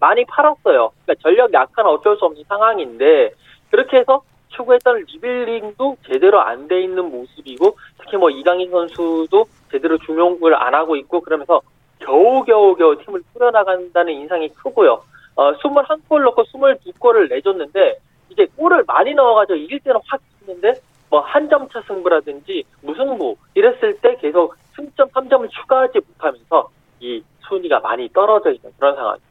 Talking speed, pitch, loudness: 345 characters per minute, 265 Hz, -16 LUFS